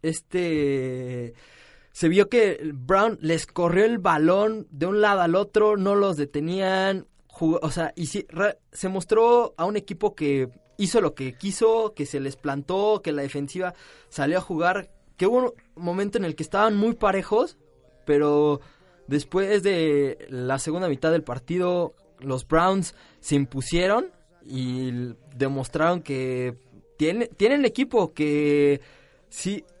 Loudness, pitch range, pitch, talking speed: -24 LUFS, 145-200 Hz, 165 Hz, 150 wpm